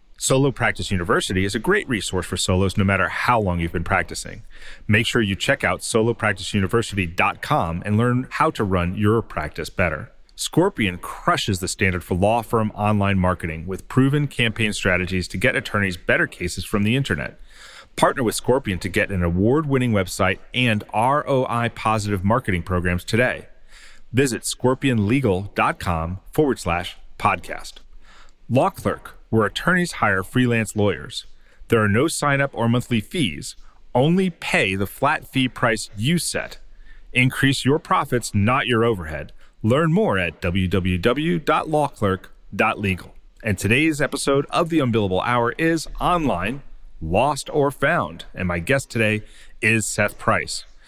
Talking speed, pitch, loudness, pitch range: 145 wpm, 110 Hz, -21 LUFS, 95-130 Hz